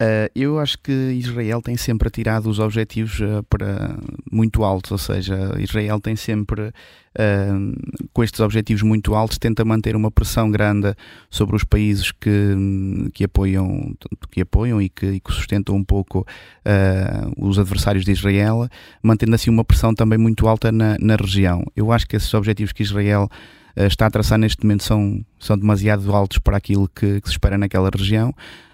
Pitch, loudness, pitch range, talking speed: 105 Hz, -19 LUFS, 100-110 Hz, 165 wpm